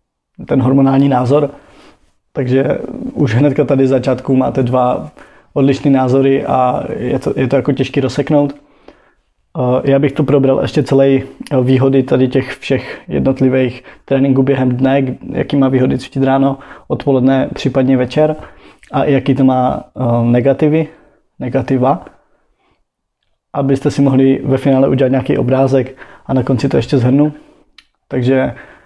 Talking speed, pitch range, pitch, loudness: 130 wpm, 130-140 Hz, 135 Hz, -13 LUFS